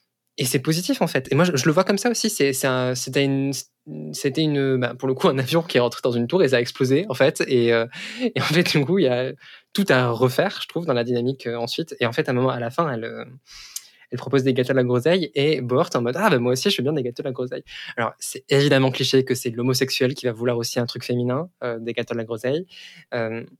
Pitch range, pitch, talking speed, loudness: 125-145 Hz, 130 Hz, 300 wpm, -22 LUFS